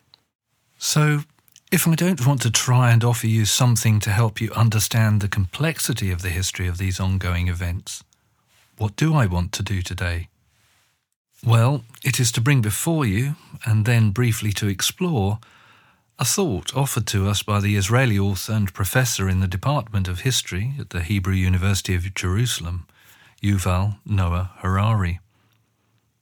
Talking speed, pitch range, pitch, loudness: 155 wpm, 95-120 Hz, 110 Hz, -21 LUFS